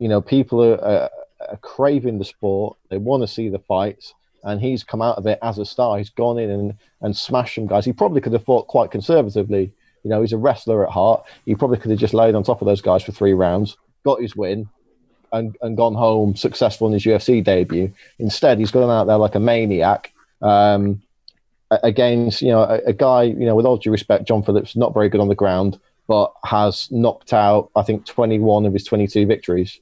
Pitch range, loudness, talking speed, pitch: 105-120 Hz, -18 LUFS, 225 wpm, 110 Hz